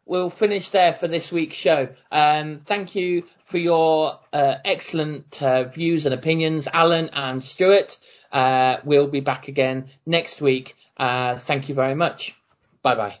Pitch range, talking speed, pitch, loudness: 135-170 Hz, 160 wpm, 150 Hz, -21 LUFS